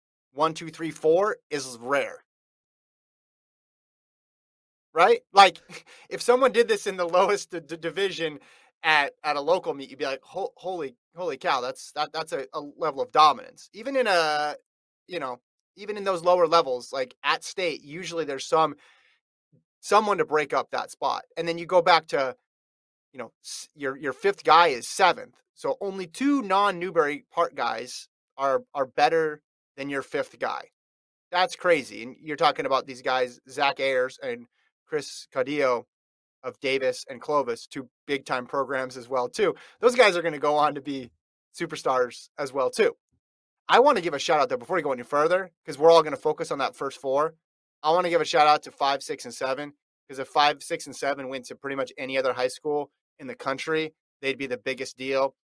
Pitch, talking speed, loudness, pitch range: 155 Hz, 195 wpm, -25 LUFS, 135-185 Hz